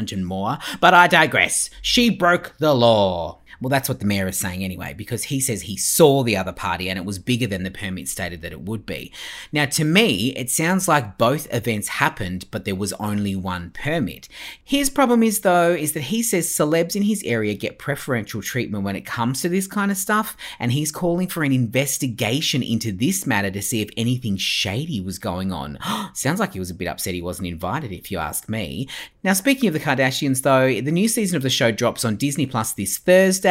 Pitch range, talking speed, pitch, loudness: 100-165 Hz, 220 wpm, 125 Hz, -20 LUFS